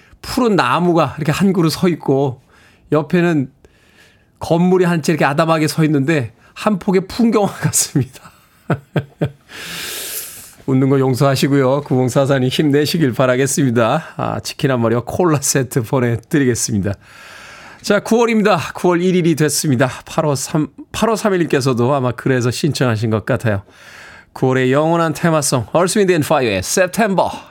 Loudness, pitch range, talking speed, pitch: -16 LUFS, 130-175 Hz, 305 characters per minute, 150 Hz